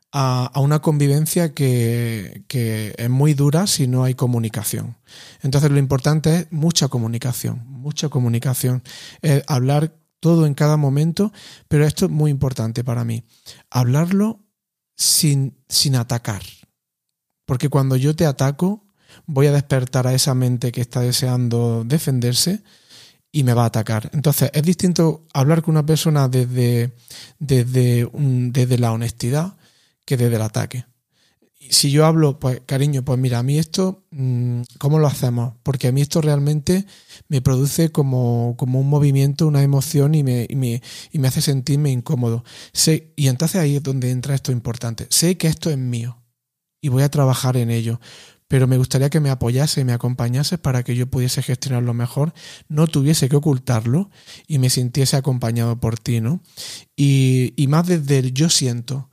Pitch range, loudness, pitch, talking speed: 125-150 Hz, -19 LUFS, 135 Hz, 165 wpm